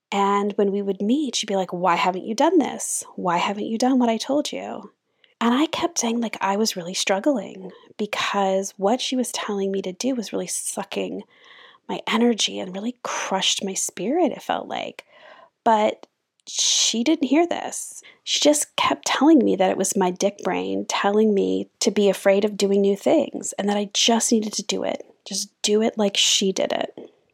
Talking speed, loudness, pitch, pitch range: 200 wpm, -22 LUFS, 215 Hz, 195-265 Hz